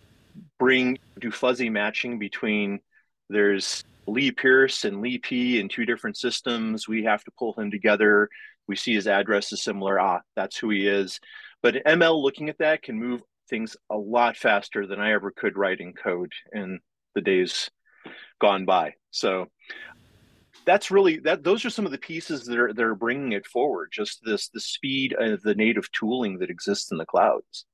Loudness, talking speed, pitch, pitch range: -24 LUFS, 185 wpm, 120 Hz, 105-135 Hz